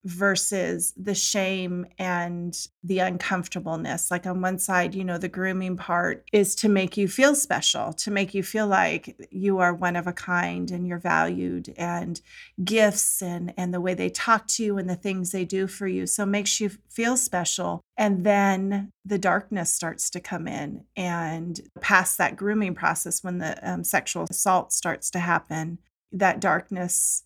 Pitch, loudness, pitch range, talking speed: 185 Hz, -25 LUFS, 175-200 Hz, 180 wpm